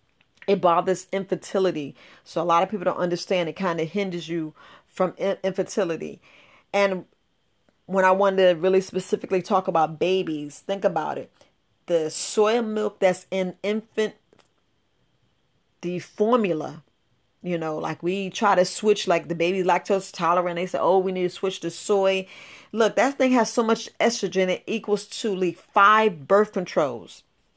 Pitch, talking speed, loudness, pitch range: 185 Hz, 160 wpm, -23 LUFS, 175-200 Hz